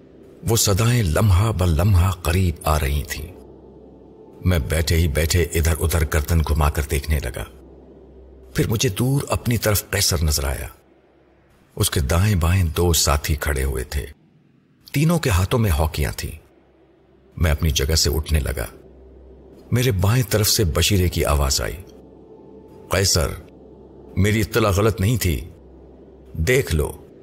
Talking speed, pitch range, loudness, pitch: 140 wpm, 75-100 Hz, -20 LUFS, 85 Hz